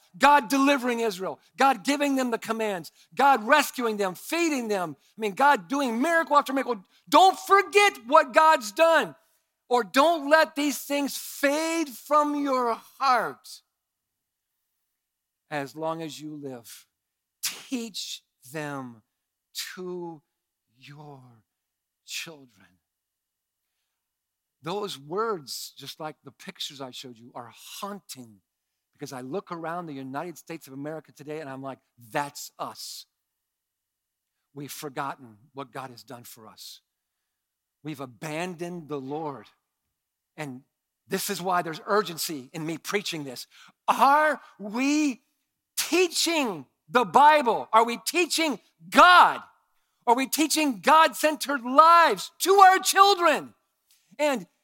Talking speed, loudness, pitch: 120 wpm, -23 LUFS, 195 Hz